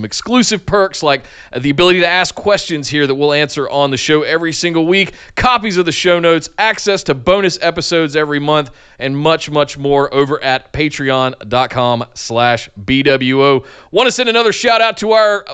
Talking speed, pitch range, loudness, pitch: 180 wpm, 140-180 Hz, -13 LUFS, 150 Hz